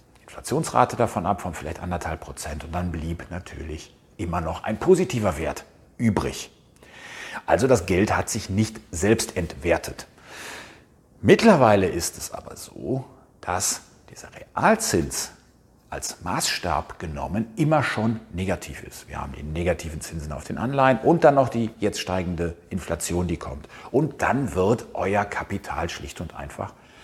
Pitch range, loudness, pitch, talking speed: 85-115 Hz, -24 LUFS, 90 Hz, 145 wpm